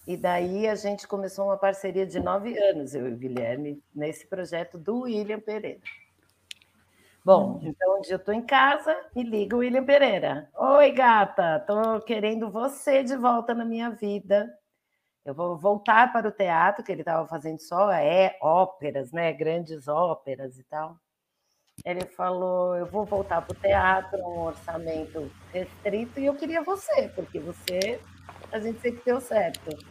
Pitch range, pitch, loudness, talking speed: 165-225 Hz, 195 Hz, -25 LUFS, 160 wpm